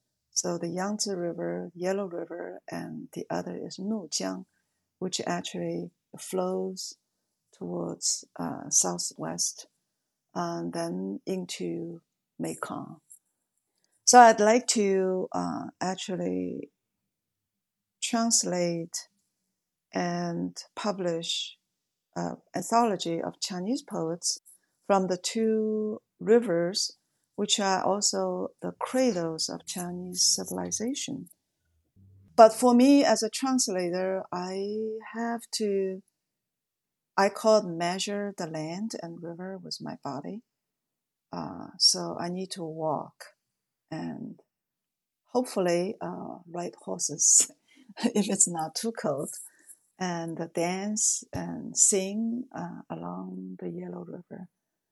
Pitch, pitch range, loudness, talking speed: 185 Hz, 165-215 Hz, -27 LUFS, 100 wpm